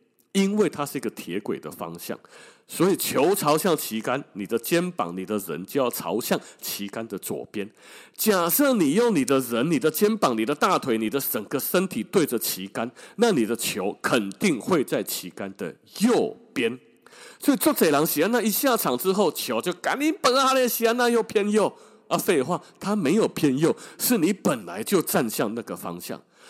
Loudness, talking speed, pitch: -24 LUFS, 260 characters per minute, 195 Hz